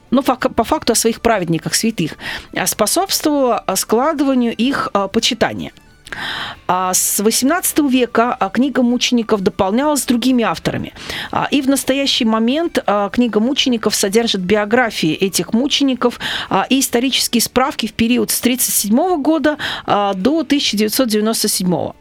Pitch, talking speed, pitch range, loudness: 235 Hz, 110 wpm, 210-265 Hz, -16 LUFS